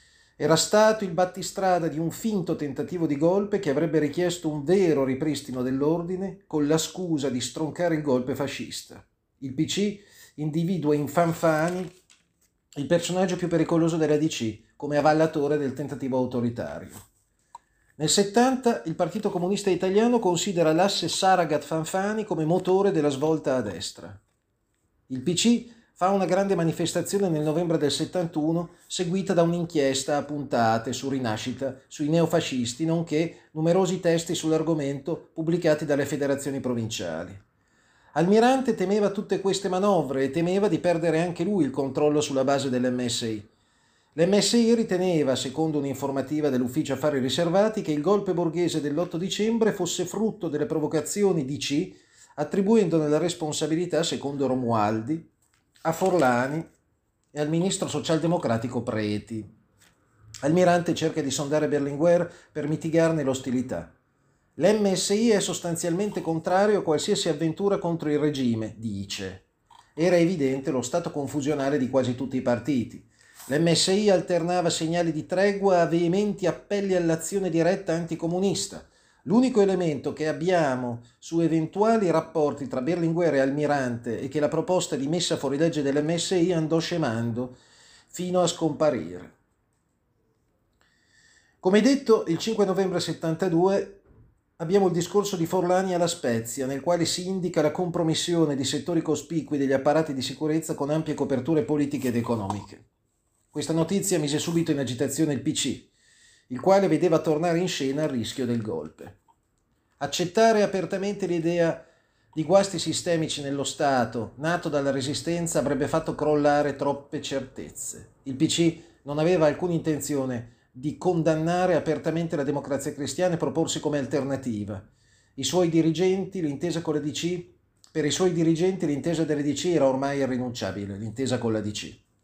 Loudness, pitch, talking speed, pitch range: -25 LUFS, 160 Hz, 135 wpm, 140-175 Hz